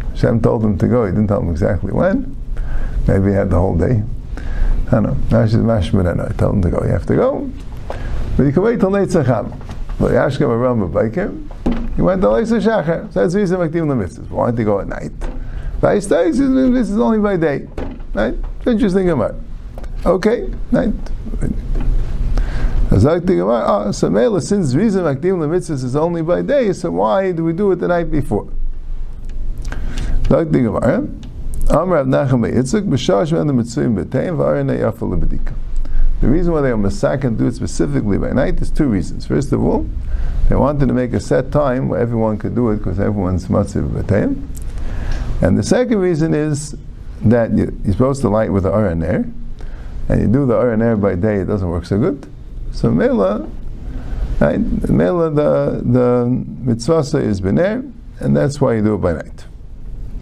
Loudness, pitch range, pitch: -17 LUFS, 100-165 Hz, 120 Hz